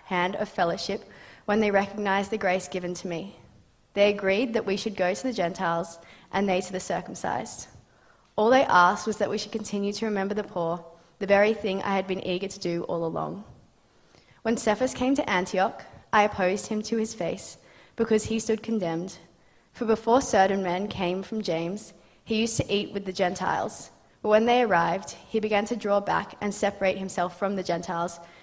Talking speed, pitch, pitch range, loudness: 195 wpm, 195 Hz, 180-215 Hz, -26 LUFS